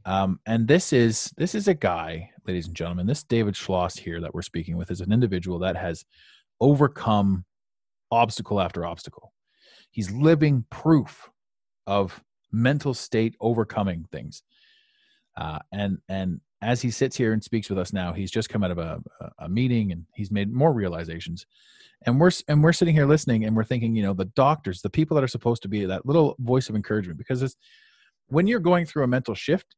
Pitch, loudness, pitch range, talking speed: 110 Hz, -24 LUFS, 95-135 Hz, 195 wpm